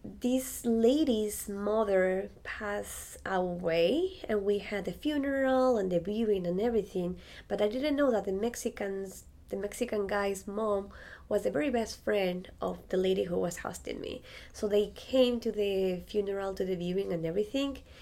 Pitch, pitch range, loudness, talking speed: 205 Hz, 190-235 Hz, -31 LUFS, 165 wpm